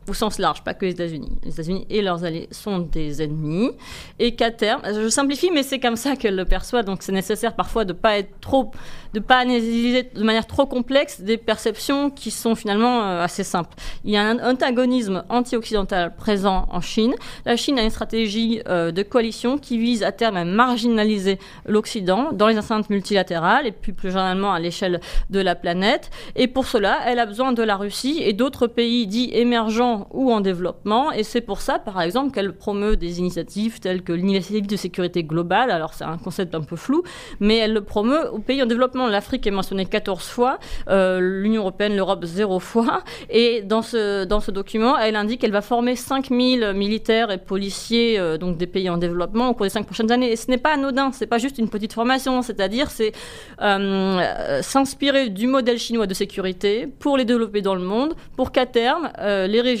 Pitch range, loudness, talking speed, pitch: 195-245 Hz, -21 LUFS, 205 wpm, 220 Hz